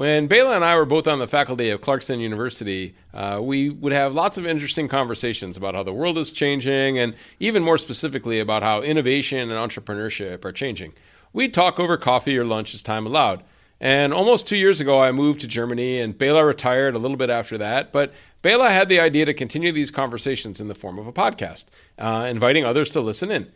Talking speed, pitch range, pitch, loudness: 215 wpm, 115-150 Hz, 135 Hz, -20 LUFS